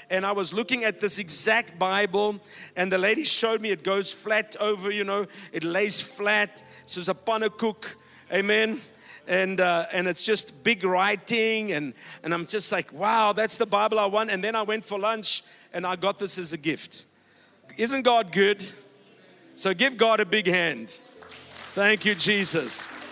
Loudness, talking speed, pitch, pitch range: -24 LUFS, 185 wpm, 205 Hz, 185-220 Hz